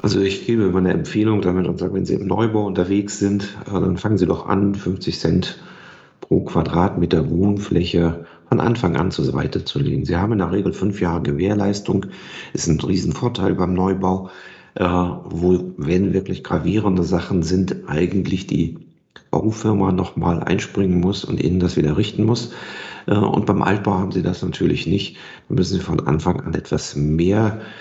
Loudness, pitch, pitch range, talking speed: -20 LUFS, 95 Hz, 90-100 Hz, 170 wpm